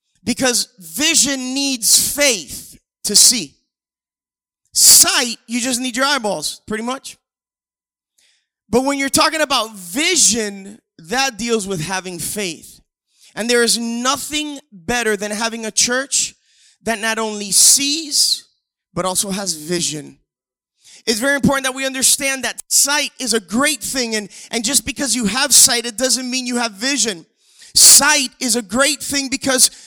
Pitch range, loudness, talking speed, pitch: 210-275 Hz, -14 LUFS, 145 wpm, 245 Hz